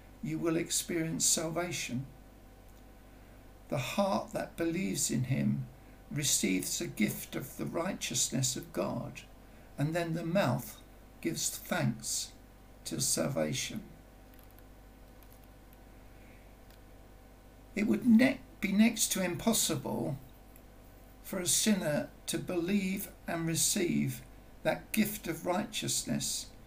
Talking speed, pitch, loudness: 100 wpm, 165 Hz, -32 LUFS